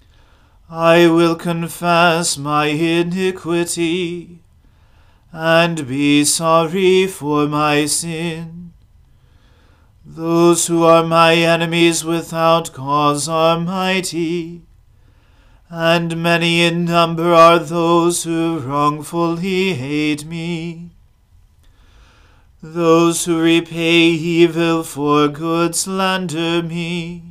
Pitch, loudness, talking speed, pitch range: 165 Hz, -15 LUFS, 85 wpm, 145-170 Hz